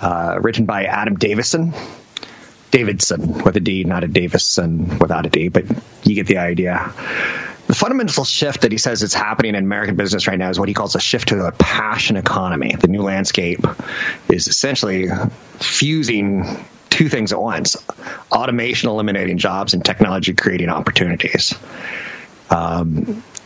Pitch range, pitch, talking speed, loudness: 95-125 Hz, 105 Hz, 155 wpm, -17 LUFS